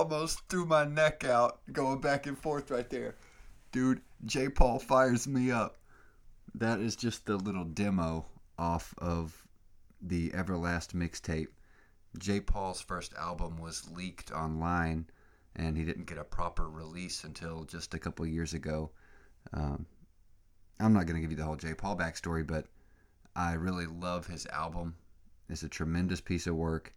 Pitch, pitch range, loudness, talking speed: 85 Hz, 80-100 Hz, -34 LUFS, 160 wpm